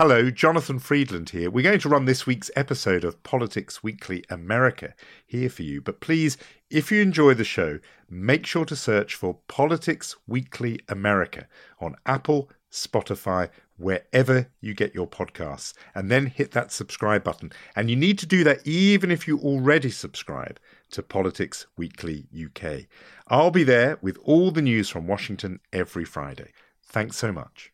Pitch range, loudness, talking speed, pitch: 95-145 Hz, -24 LUFS, 165 wpm, 120 Hz